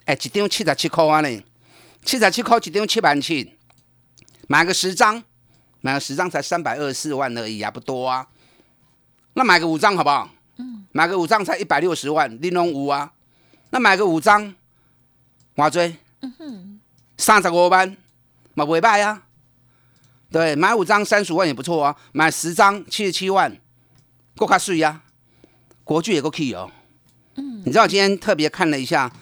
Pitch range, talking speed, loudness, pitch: 130-195 Hz, 250 characters per minute, -19 LUFS, 165 Hz